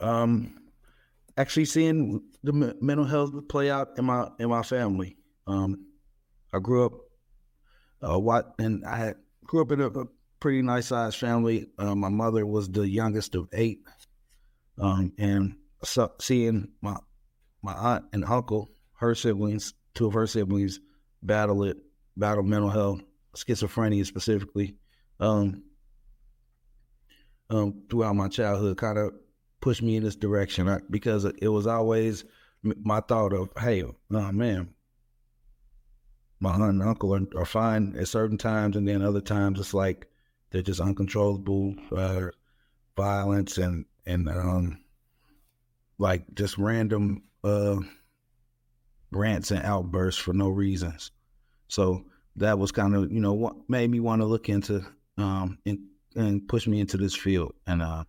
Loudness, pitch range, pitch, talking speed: -27 LUFS, 95-115 Hz, 100 Hz, 150 wpm